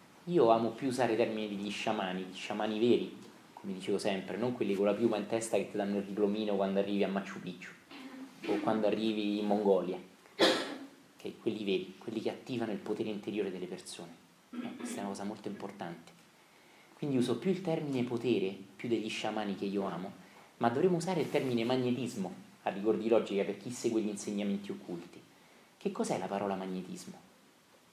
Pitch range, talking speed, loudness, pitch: 100-120 Hz, 185 wpm, -34 LUFS, 105 Hz